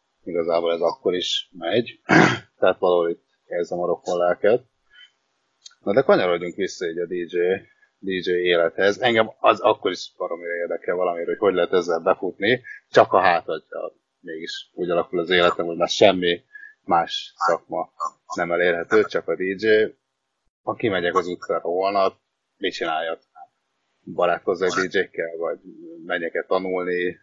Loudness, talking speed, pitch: -22 LUFS, 140 wpm, 400 Hz